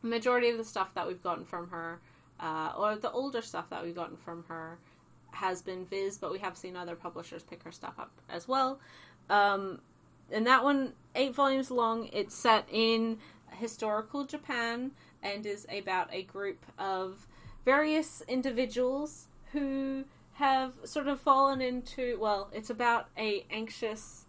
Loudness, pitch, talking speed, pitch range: -32 LUFS, 220 Hz, 160 wpm, 190-255 Hz